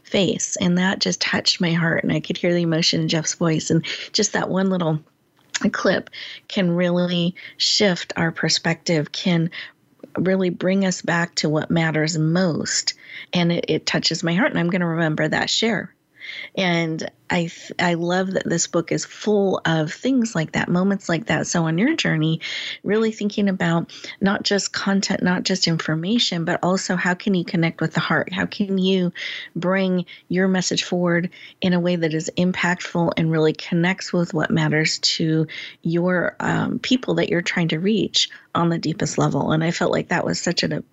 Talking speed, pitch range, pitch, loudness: 185 wpm, 165-190 Hz, 175 Hz, -21 LUFS